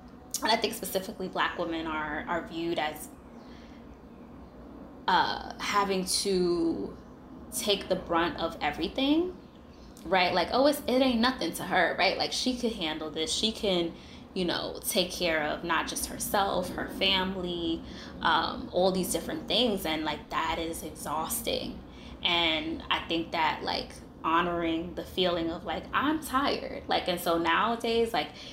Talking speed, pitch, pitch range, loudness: 150 wpm, 185 Hz, 165-235 Hz, -29 LUFS